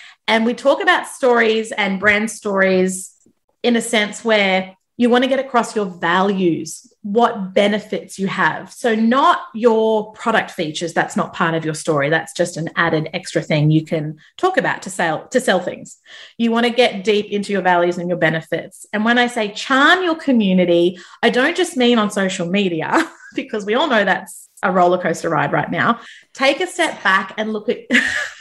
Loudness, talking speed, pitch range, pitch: -17 LUFS, 195 wpm, 175-235 Hz, 210 Hz